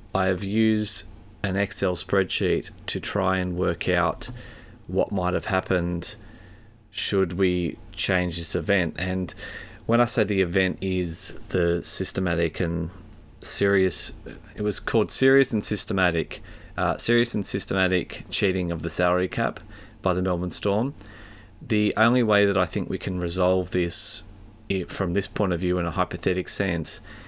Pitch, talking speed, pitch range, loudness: 95 Hz, 150 wpm, 90-105 Hz, -25 LUFS